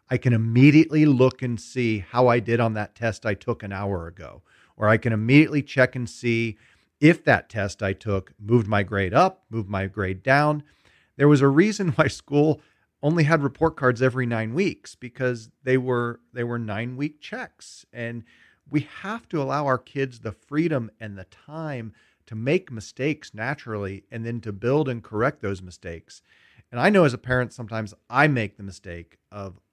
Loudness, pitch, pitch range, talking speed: -23 LUFS, 120 Hz, 105-145 Hz, 190 wpm